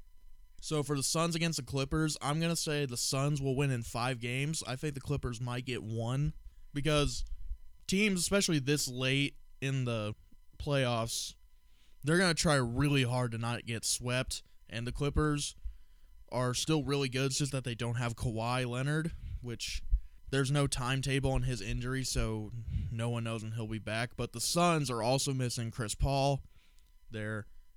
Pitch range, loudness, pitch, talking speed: 115-145 Hz, -33 LUFS, 125 Hz, 175 wpm